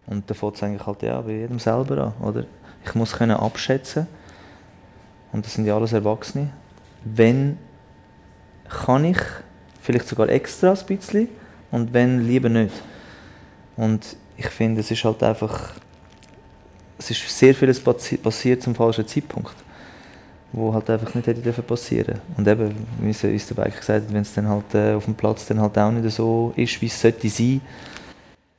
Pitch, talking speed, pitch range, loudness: 110 Hz, 160 wpm, 105-120 Hz, -22 LUFS